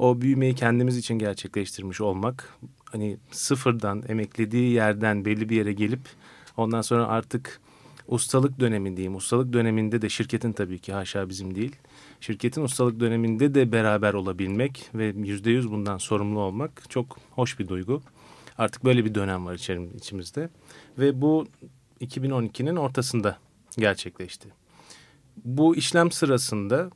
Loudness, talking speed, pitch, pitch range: -26 LUFS, 130 wpm, 115 Hz, 105-130 Hz